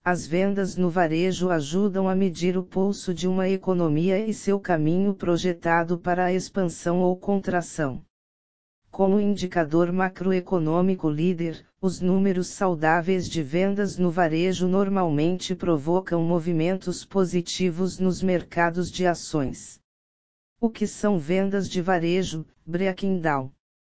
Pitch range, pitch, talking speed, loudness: 170-190 Hz, 180 Hz, 120 wpm, -24 LUFS